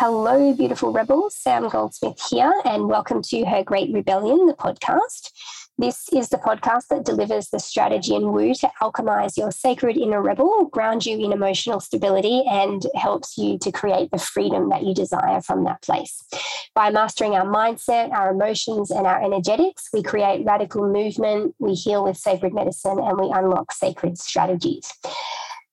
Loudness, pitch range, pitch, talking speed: -21 LUFS, 195-255 Hz, 215 Hz, 165 wpm